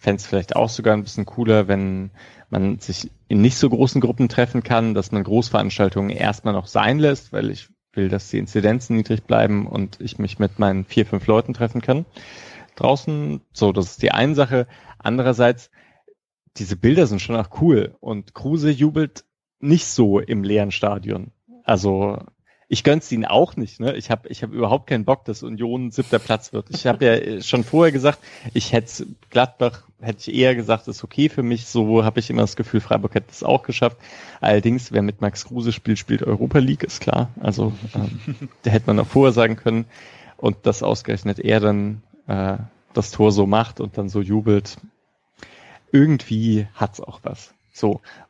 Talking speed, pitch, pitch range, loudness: 190 wpm, 115 Hz, 105-125 Hz, -20 LUFS